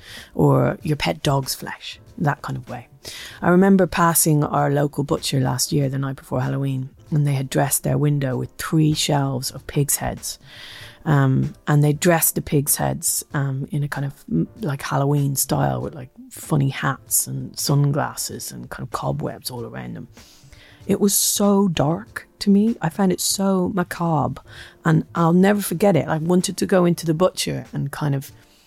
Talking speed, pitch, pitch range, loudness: 180 wpm, 145 Hz, 135-170 Hz, -20 LUFS